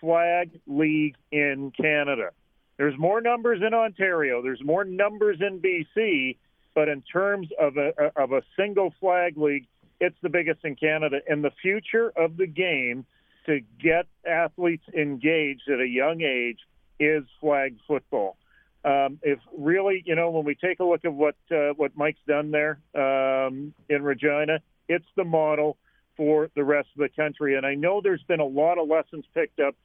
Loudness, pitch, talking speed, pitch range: -25 LUFS, 155 Hz, 175 wpm, 145-175 Hz